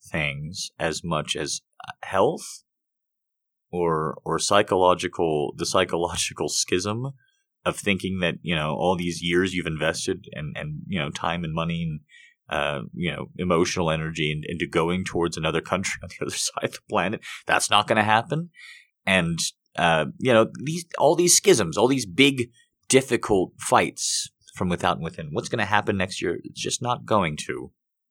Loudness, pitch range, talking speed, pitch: -24 LUFS, 85-130 Hz, 170 wpm, 90 Hz